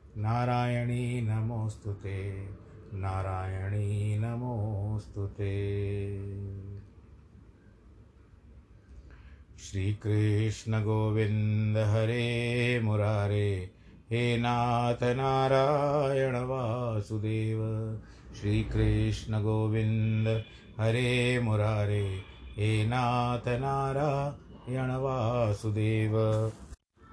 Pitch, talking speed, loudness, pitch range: 110 Hz, 40 wpm, -30 LUFS, 100-120 Hz